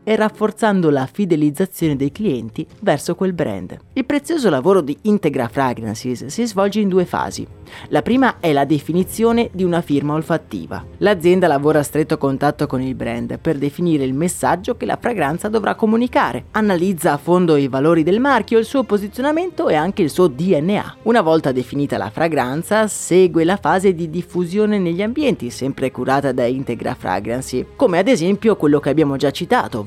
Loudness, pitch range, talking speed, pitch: -17 LUFS, 140-205 Hz, 175 wpm, 170 Hz